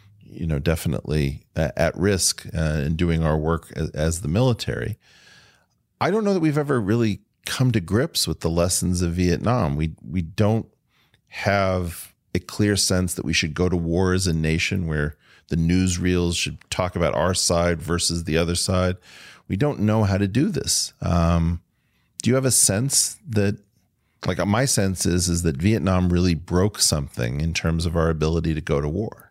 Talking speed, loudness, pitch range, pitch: 185 wpm, -22 LUFS, 80-105 Hz, 90 Hz